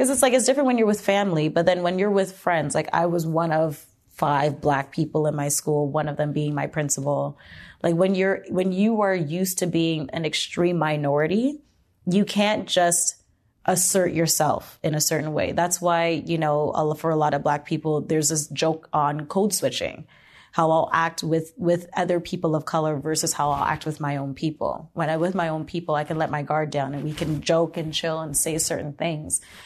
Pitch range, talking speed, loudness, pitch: 150-175 Hz, 220 wpm, -23 LUFS, 160 Hz